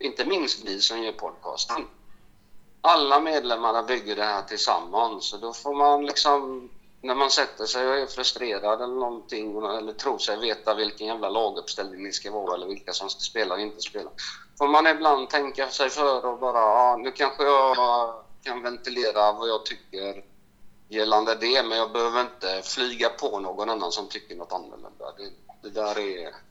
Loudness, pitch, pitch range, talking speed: -25 LUFS, 115 Hz, 105-130 Hz, 175 wpm